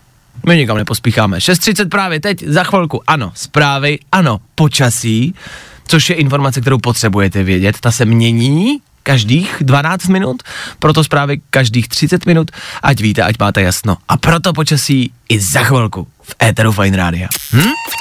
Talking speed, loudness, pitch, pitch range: 150 wpm, -12 LUFS, 135 Hz, 115-160 Hz